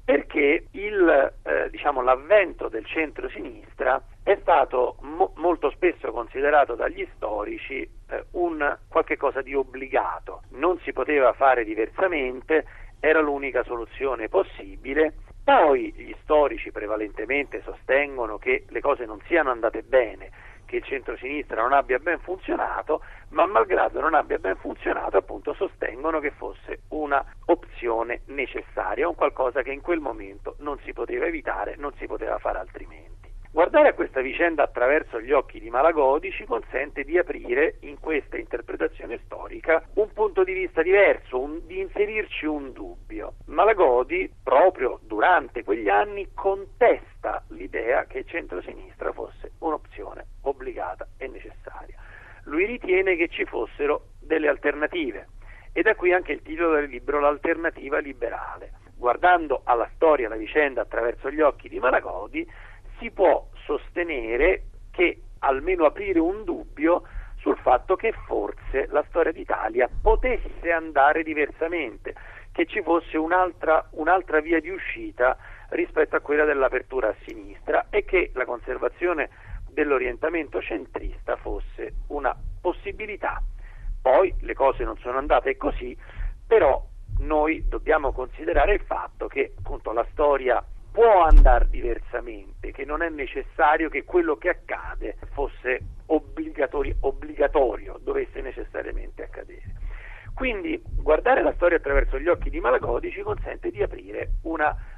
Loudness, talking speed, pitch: -24 LUFS, 135 wpm, 330 Hz